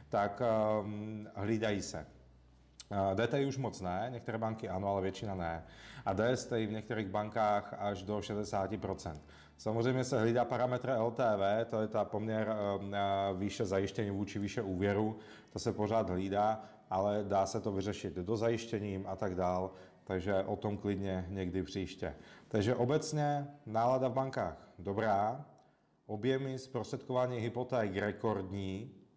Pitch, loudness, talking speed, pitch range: 105 Hz, -36 LUFS, 140 wpm, 95-115 Hz